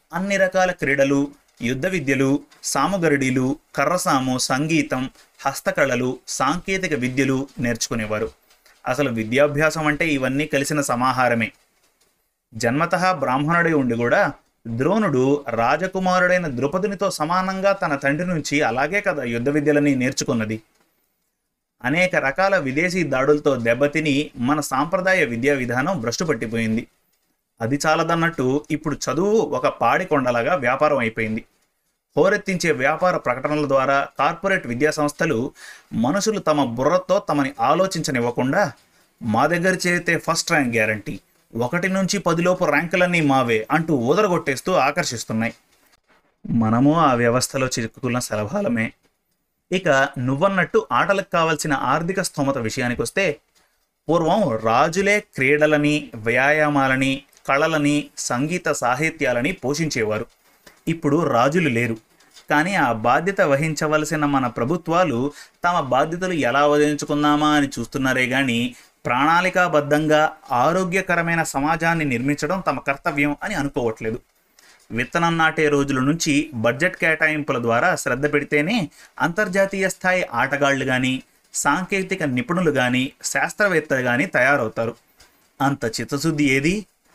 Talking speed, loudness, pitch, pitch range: 100 wpm, -20 LUFS, 145 Hz, 130-170 Hz